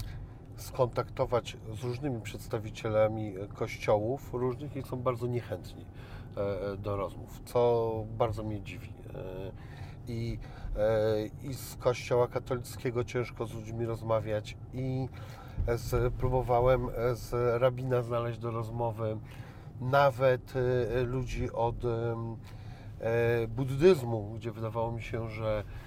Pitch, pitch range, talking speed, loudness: 115 Hz, 110-125 Hz, 95 wpm, -32 LUFS